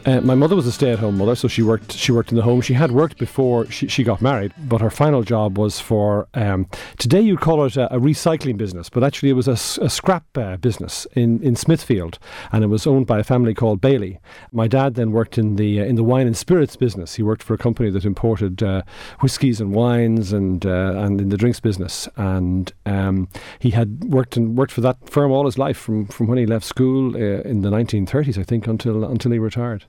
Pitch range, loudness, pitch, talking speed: 105-130 Hz, -19 LUFS, 115 Hz, 240 wpm